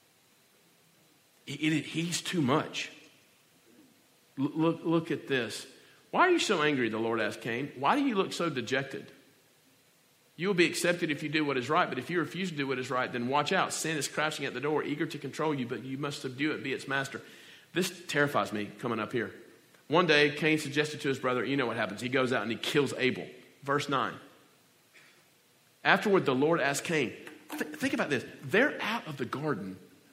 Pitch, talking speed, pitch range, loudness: 145 Hz, 200 wpm, 125-160 Hz, -30 LUFS